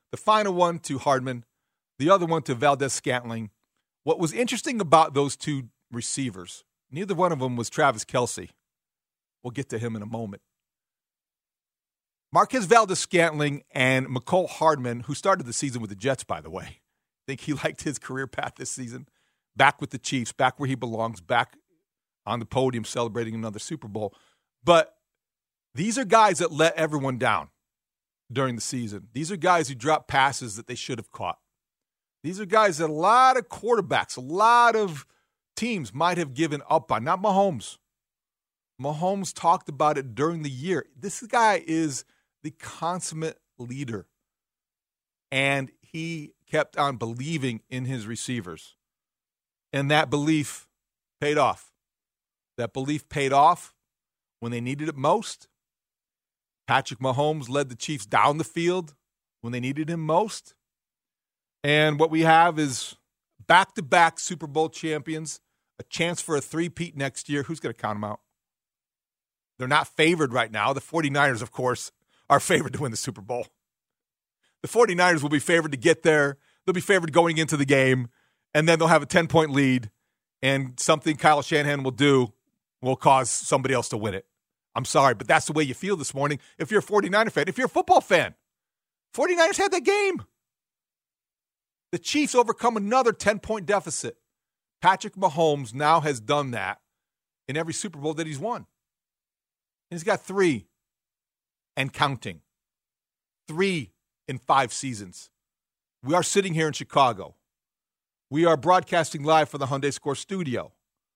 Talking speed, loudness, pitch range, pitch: 165 wpm, -24 LUFS, 130-170 Hz, 150 Hz